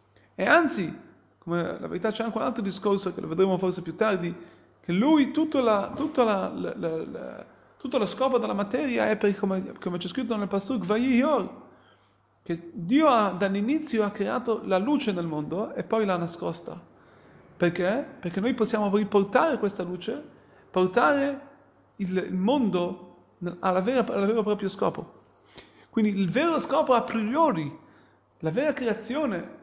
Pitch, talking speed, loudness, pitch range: 210 Hz, 150 wpm, -26 LUFS, 185-250 Hz